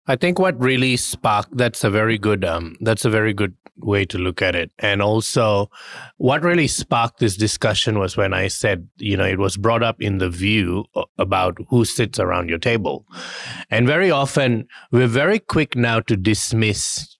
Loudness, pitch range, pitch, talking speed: -19 LUFS, 100-125 Hz, 110 Hz, 190 wpm